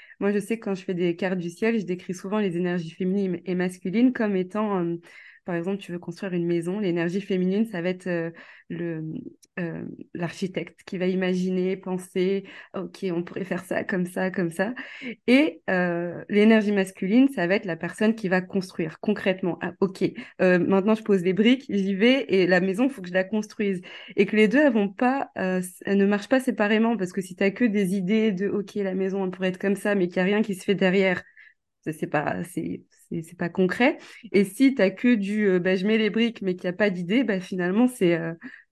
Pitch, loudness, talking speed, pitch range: 190 Hz, -24 LUFS, 235 wpm, 180-210 Hz